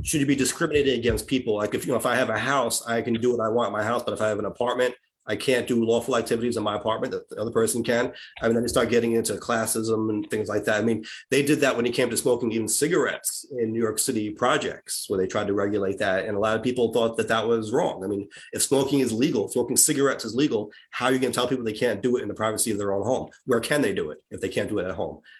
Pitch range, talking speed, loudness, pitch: 110-125 Hz, 300 wpm, -24 LUFS, 115 Hz